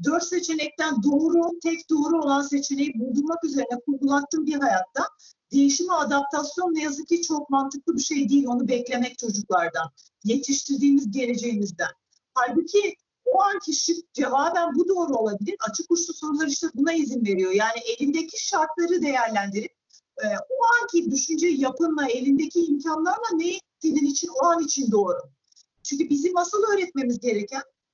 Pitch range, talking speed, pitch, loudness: 255-330 Hz, 135 wpm, 290 Hz, -24 LUFS